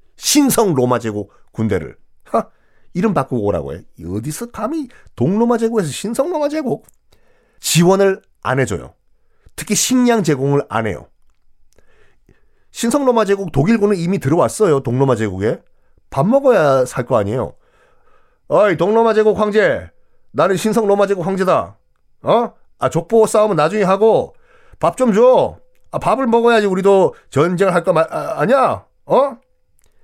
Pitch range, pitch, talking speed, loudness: 145-230 Hz, 200 Hz, 280 characters per minute, -16 LUFS